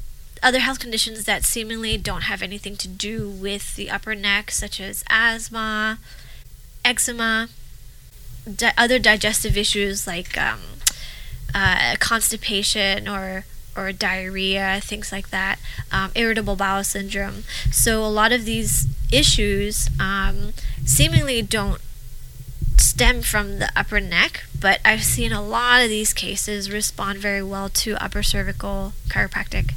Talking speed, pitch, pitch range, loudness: 130 wpm, 200 Hz, 195-220 Hz, -20 LUFS